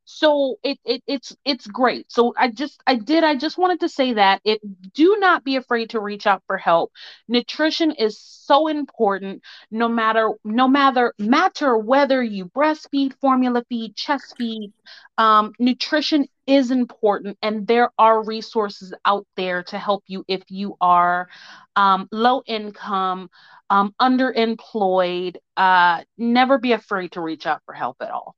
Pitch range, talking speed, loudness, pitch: 200-270 Hz, 160 wpm, -20 LUFS, 230 Hz